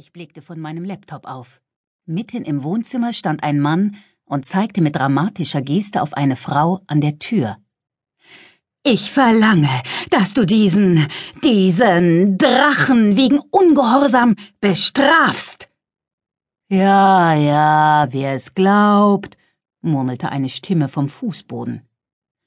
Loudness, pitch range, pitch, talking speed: -15 LUFS, 150-210 Hz, 180 Hz, 115 wpm